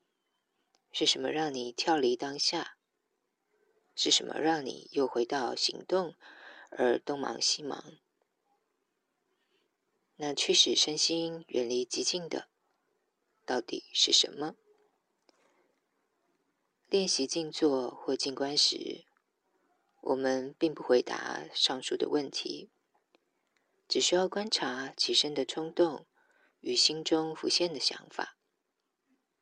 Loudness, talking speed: -30 LUFS, 155 characters per minute